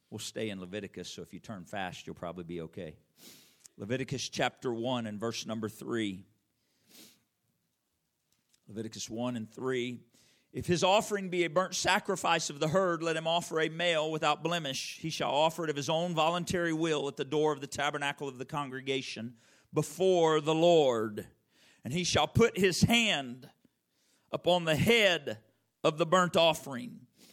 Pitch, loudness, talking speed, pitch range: 150 Hz, -30 LUFS, 165 wpm, 115-170 Hz